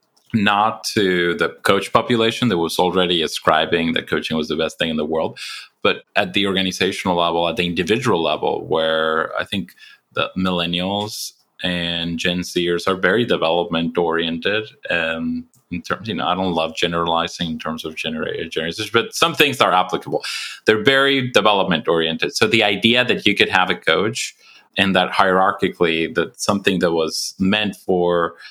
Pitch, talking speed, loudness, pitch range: 90 Hz, 170 wpm, -19 LUFS, 85-100 Hz